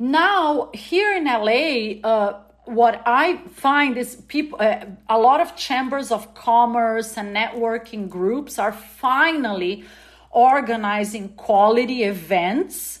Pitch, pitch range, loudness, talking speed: 230 Hz, 210-265 Hz, -20 LUFS, 115 wpm